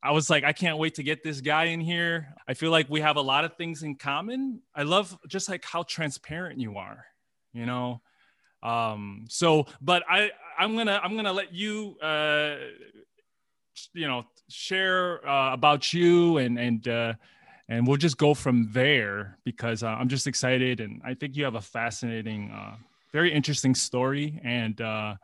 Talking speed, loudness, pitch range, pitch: 190 wpm, -26 LUFS, 125-170 Hz, 150 Hz